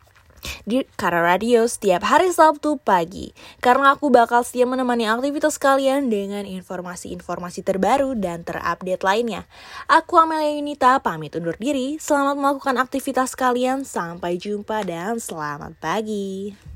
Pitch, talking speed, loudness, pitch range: 235 Hz, 125 wpm, -20 LUFS, 185-270 Hz